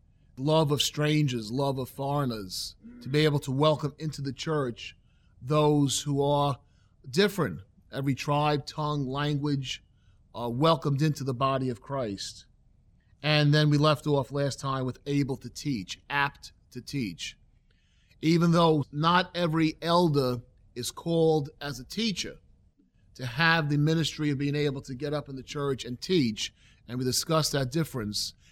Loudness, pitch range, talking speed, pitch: -28 LUFS, 125-150 Hz, 155 wpm, 140 Hz